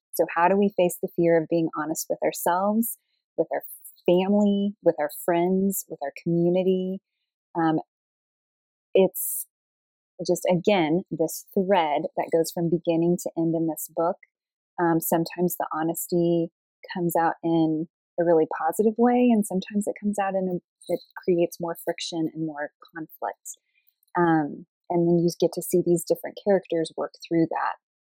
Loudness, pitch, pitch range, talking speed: -25 LUFS, 175 Hz, 165-190 Hz, 155 wpm